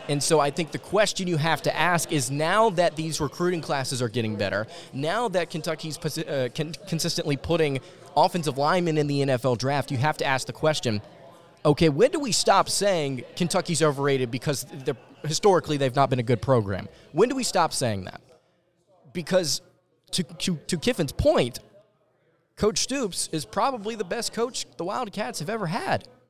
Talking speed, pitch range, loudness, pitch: 175 wpm, 140-180 Hz, -25 LUFS, 160 Hz